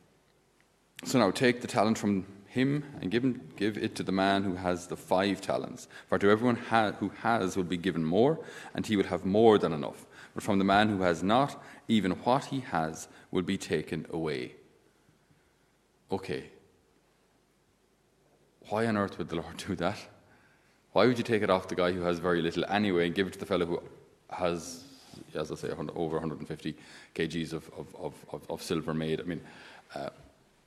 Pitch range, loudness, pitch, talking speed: 90-110 Hz, -30 LUFS, 95 Hz, 185 wpm